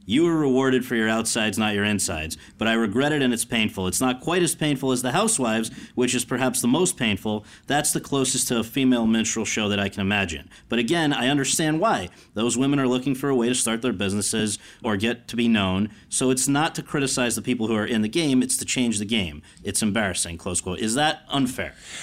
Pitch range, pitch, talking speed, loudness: 105-130 Hz, 120 Hz, 235 wpm, -23 LUFS